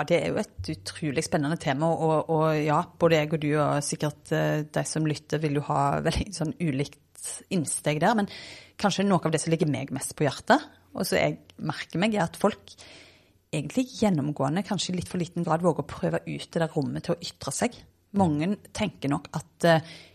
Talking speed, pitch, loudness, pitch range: 215 wpm, 160 Hz, -27 LUFS, 150-175 Hz